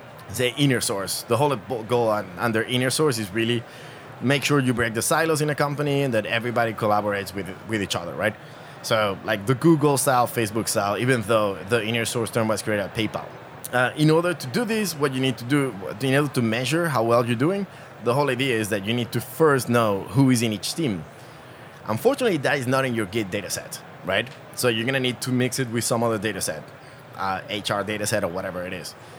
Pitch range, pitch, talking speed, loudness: 110-135 Hz, 120 Hz, 230 wpm, -23 LUFS